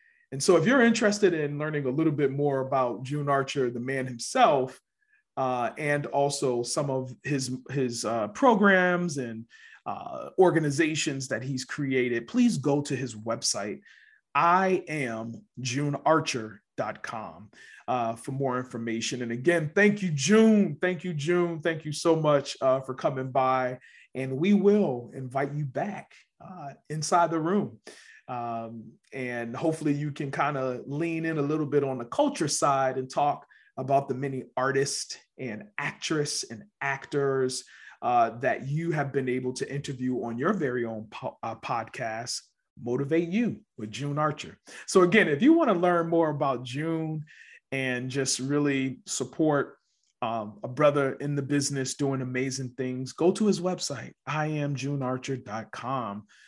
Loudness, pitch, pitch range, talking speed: -27 LUFS, 140 Hz, 130-165 Hz, 155 wpm